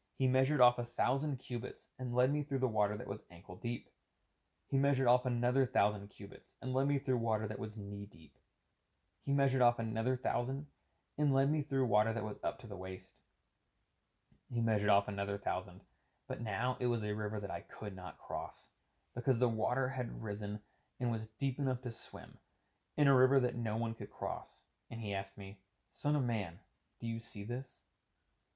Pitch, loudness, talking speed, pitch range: 120 Hz, -36 LUFS, 195 wpm, 105-130 Hz